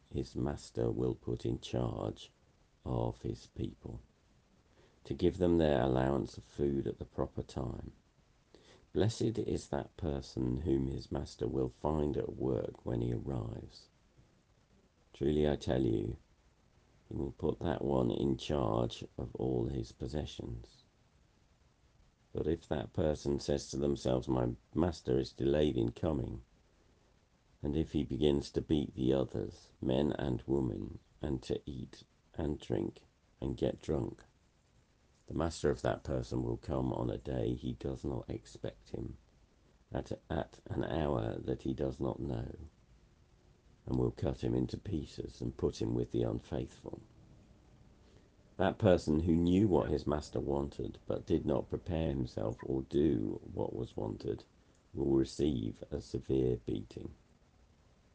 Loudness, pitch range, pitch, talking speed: -36 LUFS, 65-75 Hz, 70 Hz, 145 wpm